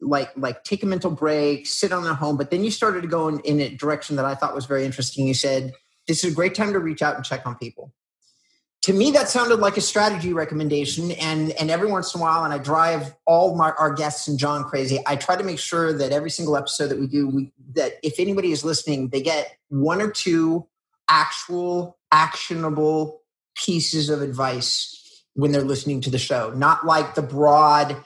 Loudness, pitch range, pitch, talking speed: -21 LUFS, 145-175 Hz, 155 Hz, 220 wpm